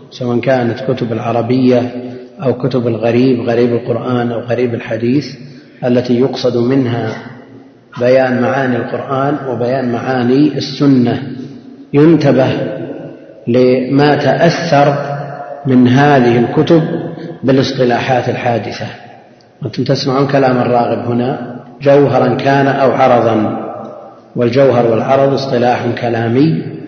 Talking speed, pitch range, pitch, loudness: 95 wpm, 120-135 Hz, 125 Hz, -12 LUFS